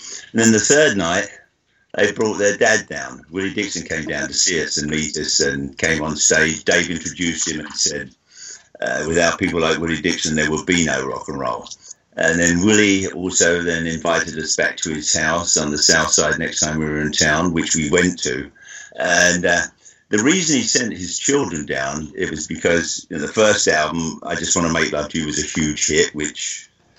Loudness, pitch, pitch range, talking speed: -18 LUFS, 80 Hz, 75-90 Hz, 215 wpm